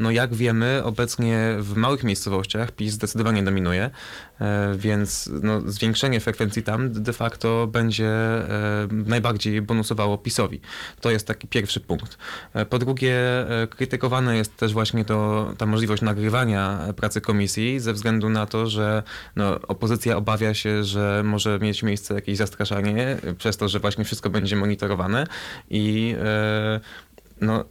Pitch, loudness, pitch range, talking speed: 110 Hz, -23 LUFS, 105-115 Hz, 135 wpm